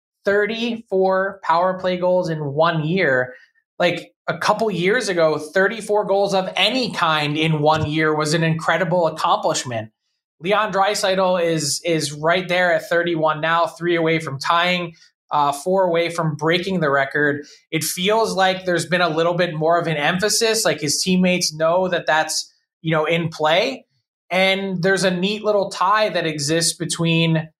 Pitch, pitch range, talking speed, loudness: 170 Hz, 160-190 Hz, 165 wpm, -19 LUFS